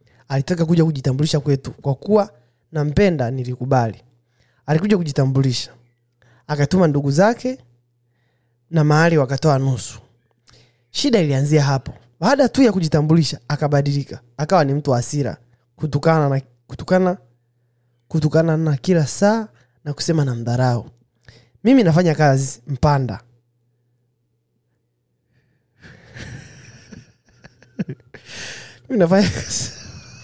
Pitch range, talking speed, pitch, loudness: 120-160 Hz, 85 wpm, 135 Hz, -18 LUFS